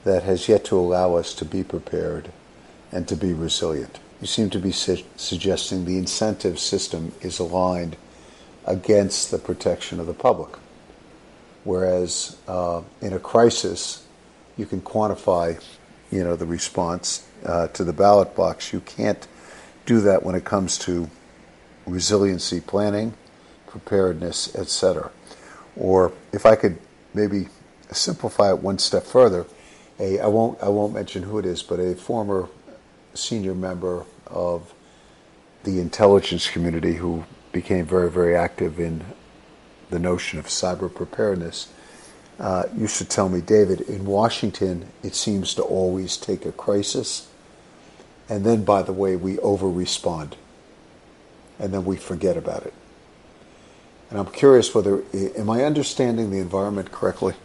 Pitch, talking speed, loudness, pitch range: 95 Hz, 145 wpm, -22 LUFS, 85-100 Hz